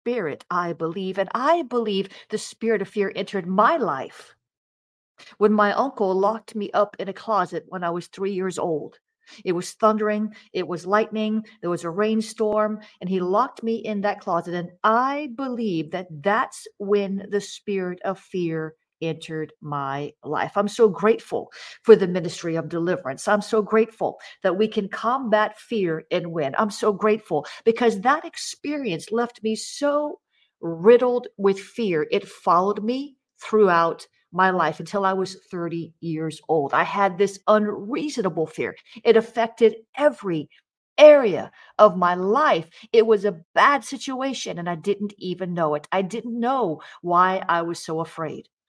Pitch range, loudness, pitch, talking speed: 175-225 Hz, -23 LUFS, 205 Hz, 160 wpm